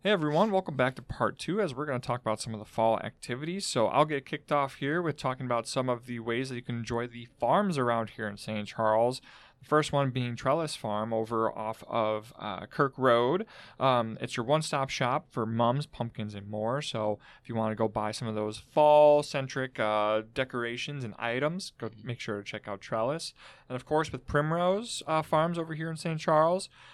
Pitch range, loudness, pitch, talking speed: 110-150 Hz, -30 LUFS, 125 Hz, 225 wpm